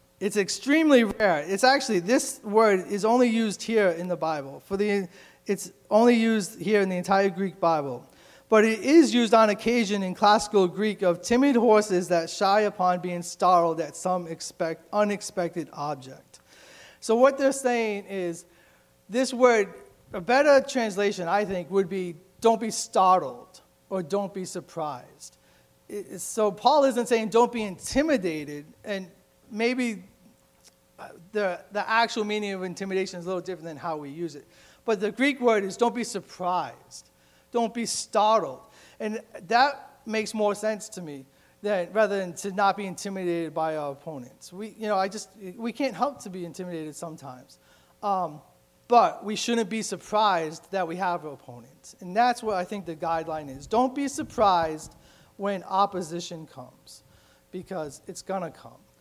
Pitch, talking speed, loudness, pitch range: 195 Hz, 165 wpm, -25 LUFS, 175-220 Hz